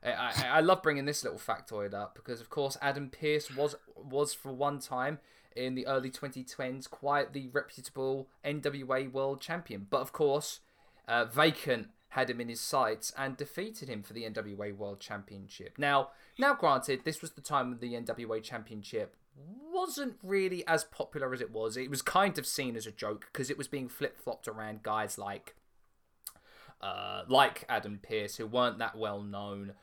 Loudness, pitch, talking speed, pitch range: -34 LUFS, 135 Hz, 180 wpm, 110-145 Hz